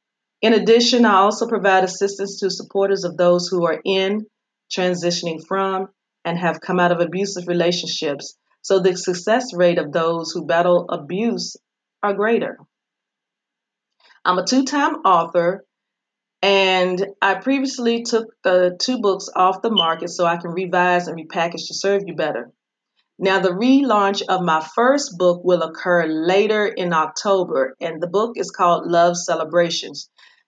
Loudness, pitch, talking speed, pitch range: -19 LUFS, 185 Hz, 150 wpm, 175-205 Hz